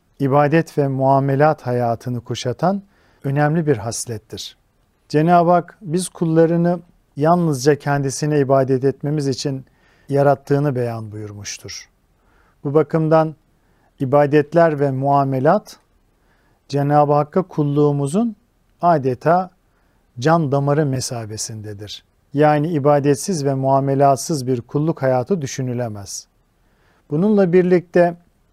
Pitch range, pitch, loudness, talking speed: 125-160 Hz, 145 Hz, -18 LUFS, 90 wpm